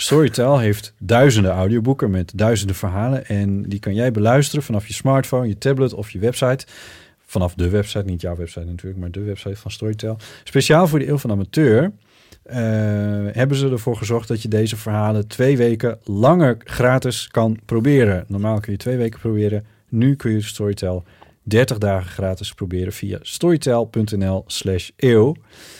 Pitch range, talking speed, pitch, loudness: 100-125 Hz, 160 wpm, 110 Hz, -19 LUFS